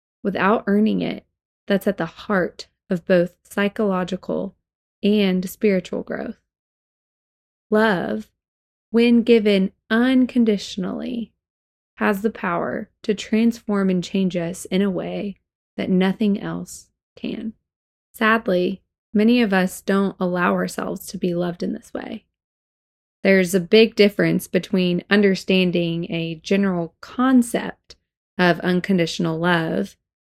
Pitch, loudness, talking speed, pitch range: 195 Hz, -21 LUFS, 115 wpm, 180-215 Hz